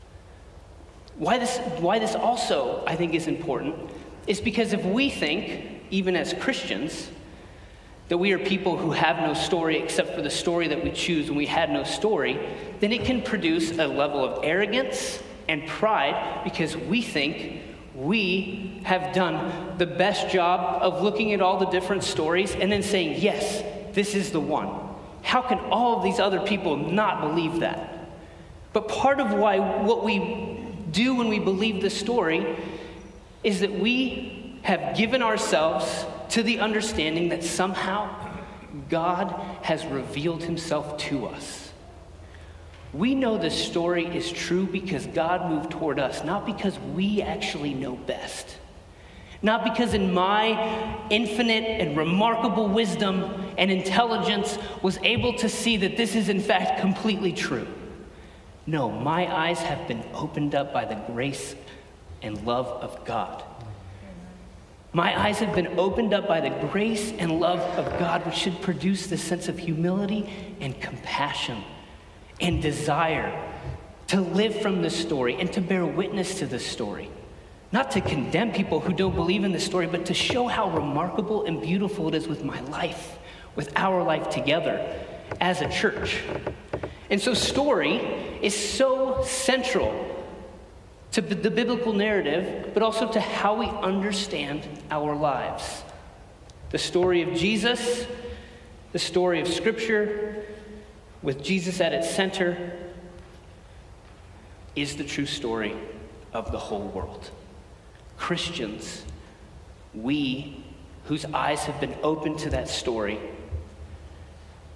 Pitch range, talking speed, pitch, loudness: 150-210 Hz, 145 wpm, 180 Hz, -26 LUFS